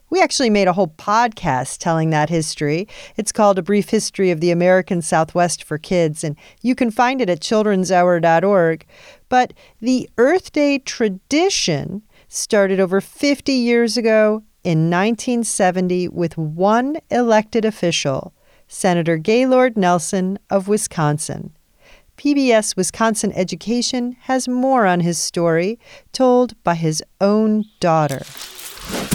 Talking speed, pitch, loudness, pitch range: 125 wpm, 200 Hz, -17 LUFS, 175-235 Hz